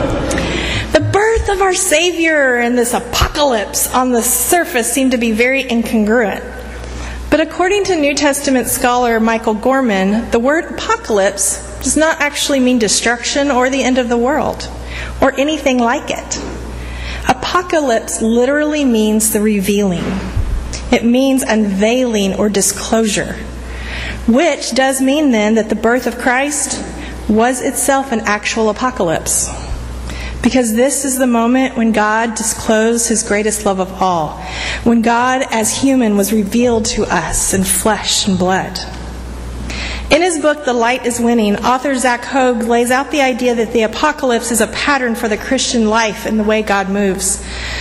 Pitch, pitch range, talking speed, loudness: 235 Hz, 205-265 Hz, 150 wpm, -14 LUFS